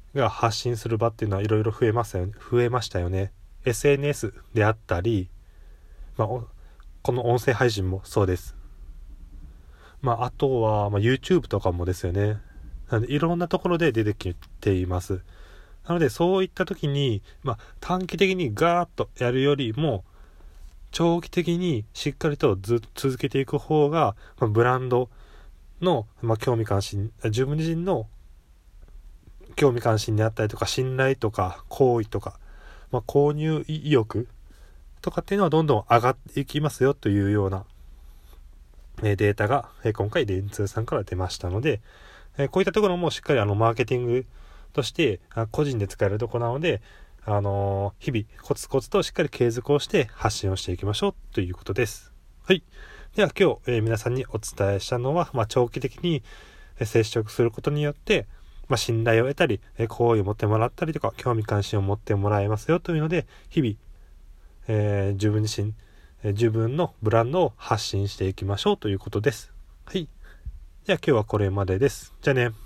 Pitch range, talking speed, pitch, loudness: 95-135 Hz, 335 characters per minute, 110 Hz, -25 LUFS